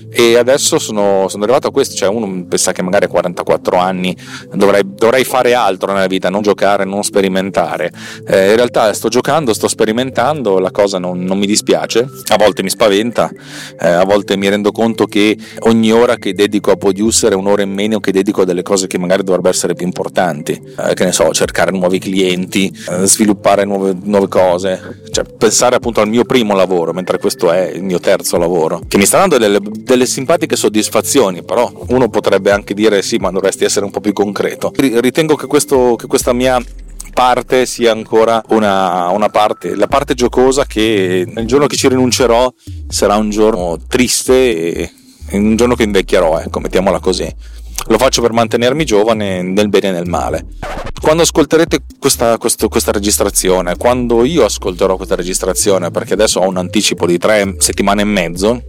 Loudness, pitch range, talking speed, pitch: -12 LUFS, 95-120 Hz, 185 wpm, 105 Hz